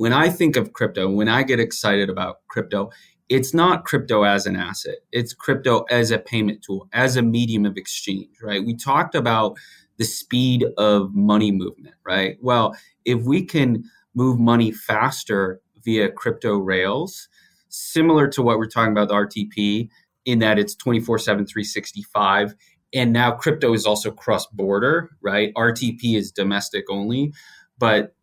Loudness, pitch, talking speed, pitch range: -20 LUFS, 110 Hz, 155 wpm, 105-120 Hz